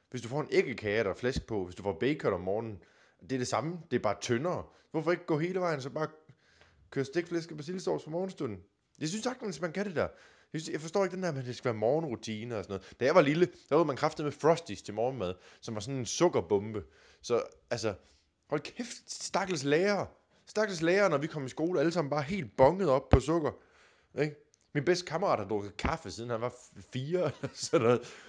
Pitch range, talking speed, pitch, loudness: 120-175 Hz, 225 wpm, 150 Hz, -32 LUFS